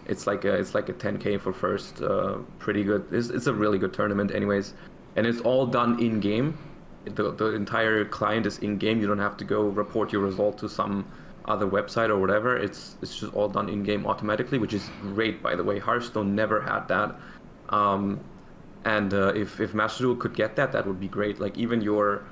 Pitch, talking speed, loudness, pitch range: 105 Hz, 215 wpm, -27 LUFS, 100-110 Hz